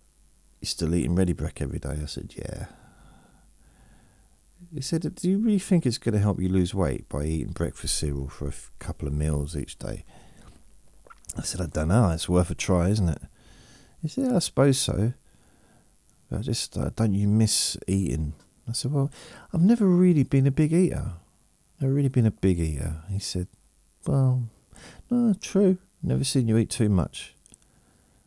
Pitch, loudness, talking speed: 95 Hz, -25 LUFS, 180 wpm